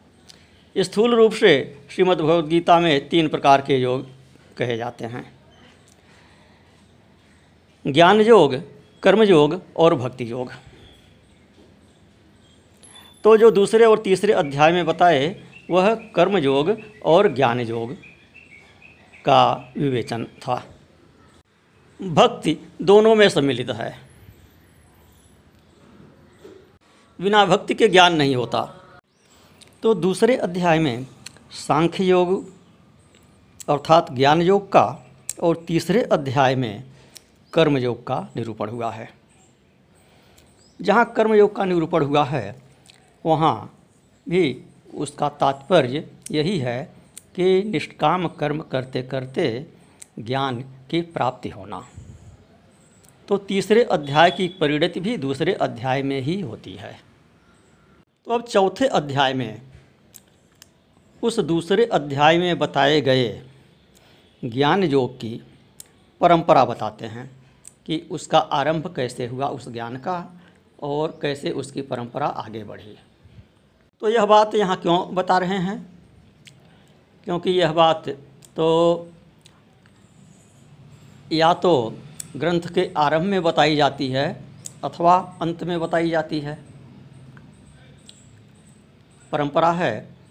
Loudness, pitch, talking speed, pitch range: -20 LUFS, 155 Hz, 105 wpm, 130-180 Hz